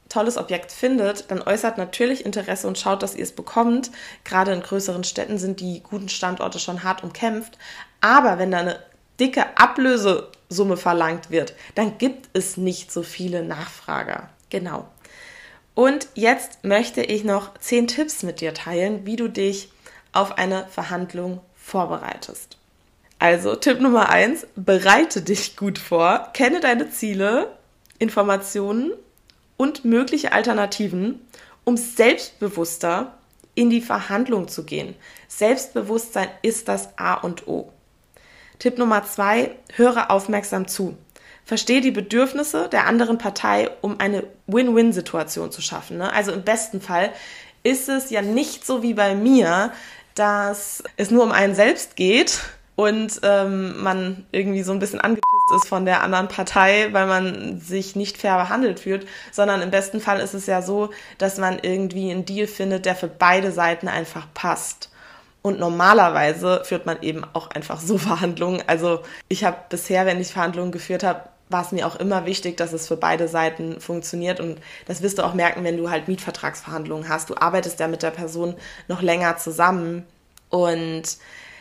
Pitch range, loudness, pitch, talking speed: 180-225 Hz, -21 LUFS, 195 Hz, 155 wpm